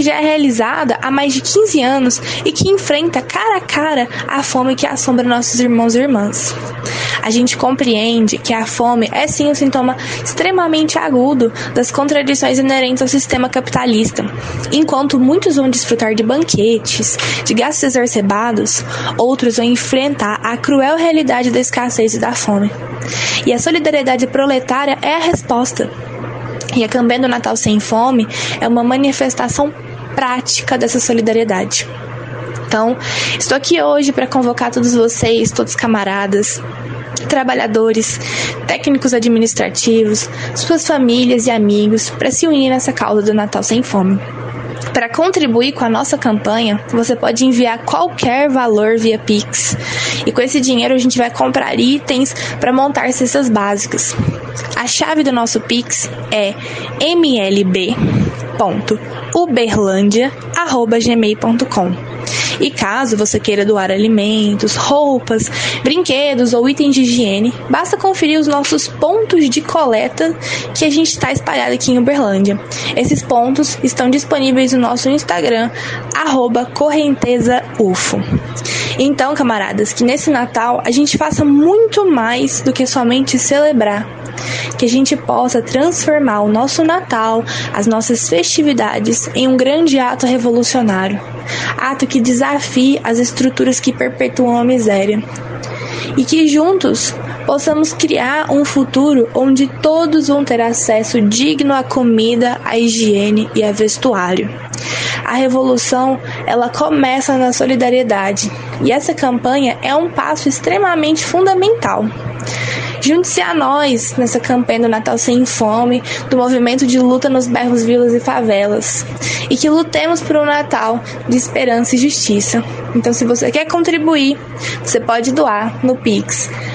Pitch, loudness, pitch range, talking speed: 245 Hz, -13 LUFS, 220-275 Hz, 135 wpm